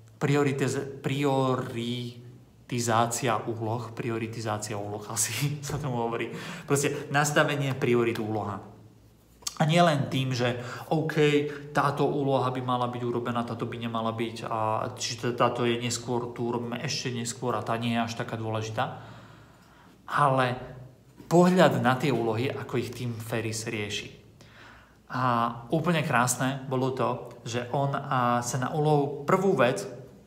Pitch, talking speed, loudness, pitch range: 120 Hz, 135 wpm, -28 LUFS, 115-140 Hz